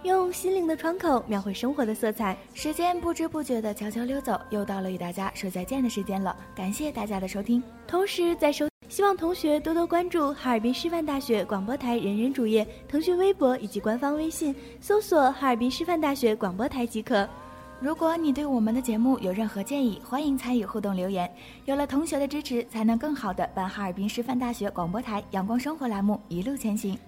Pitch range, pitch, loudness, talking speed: 210-295 Hz, 245 Hz, -27 LUFS, 330 characters per minute